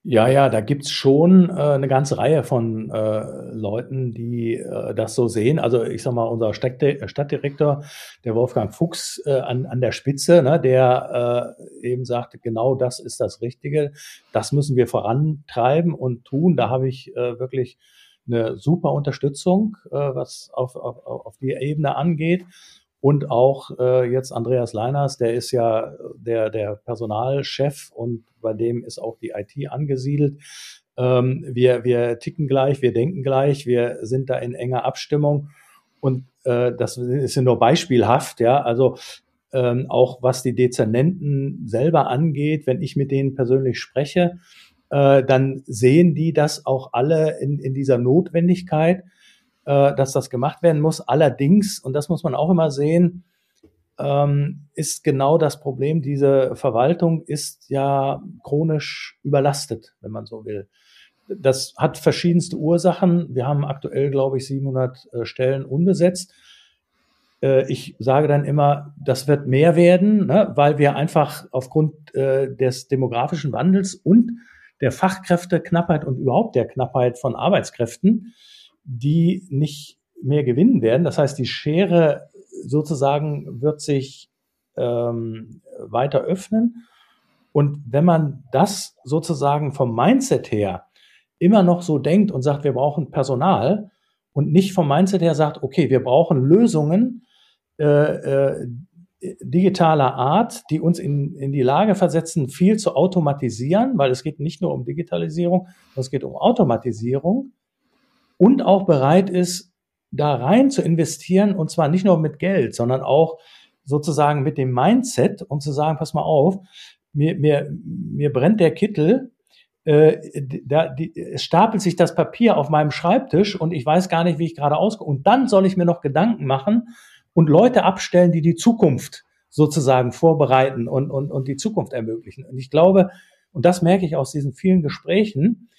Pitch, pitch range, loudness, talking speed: 145 Hz, 130-175 Hz, -19 LUFS, 155 wpm